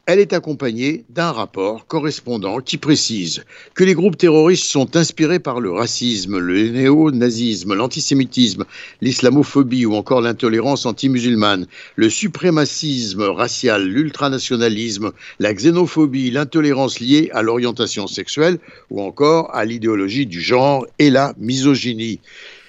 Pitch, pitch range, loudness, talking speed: 130 Hz, 115-150 Hz, -17 LUFS, 120 wpm